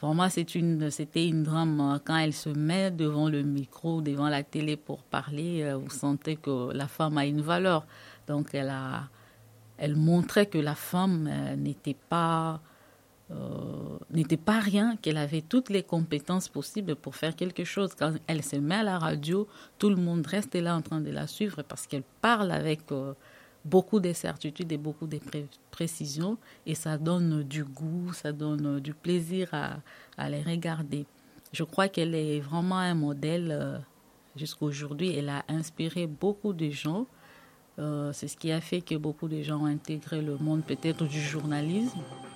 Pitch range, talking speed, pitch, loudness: 145-170 Hz, 180 wpm, 155 Hz, -30 LUFS